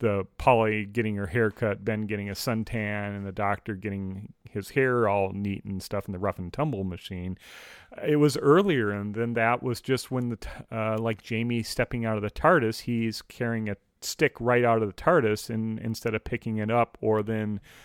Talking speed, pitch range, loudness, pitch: 205 wpm, 100-120 Hz, -27 LUFS, 110 Hz